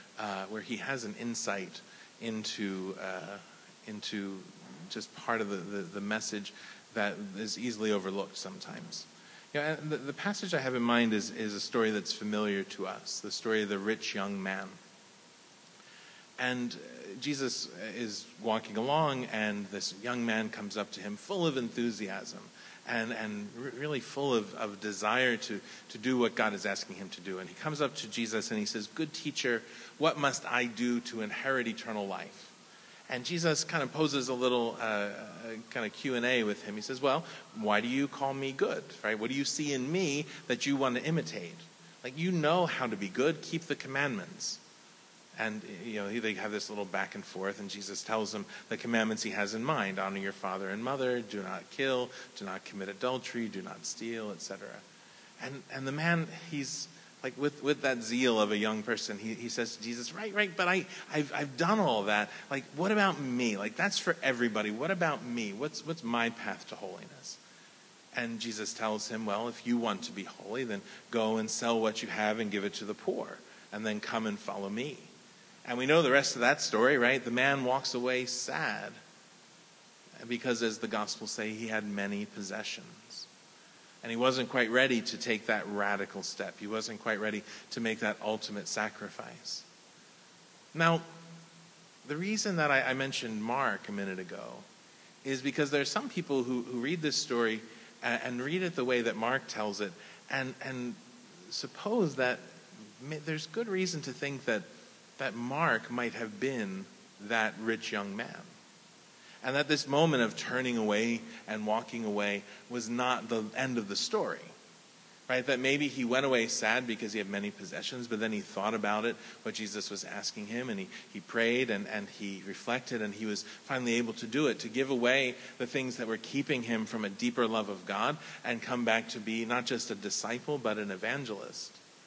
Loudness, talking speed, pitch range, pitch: -33 LUFS, 195 wpm, 105-140 Hz, 120 Hz